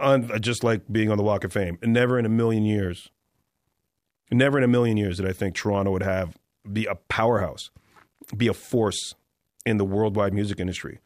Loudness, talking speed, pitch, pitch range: -24 LUFS, 190 wpm, 105 Hz, 95-115 Hz